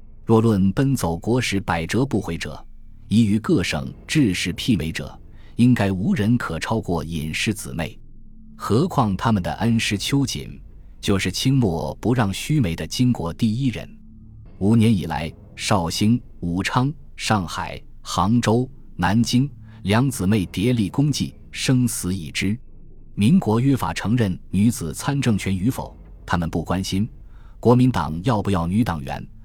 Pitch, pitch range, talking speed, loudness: 105 Hz, 85-120 Hz, 215 characters per minute, -21 LUFS